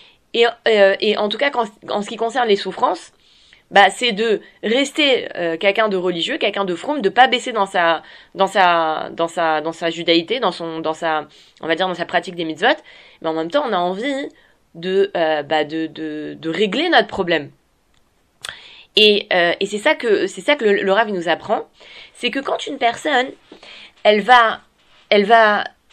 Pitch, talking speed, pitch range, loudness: 195 Hz, 205 wpm, 170-230 Hz, -17 LUFS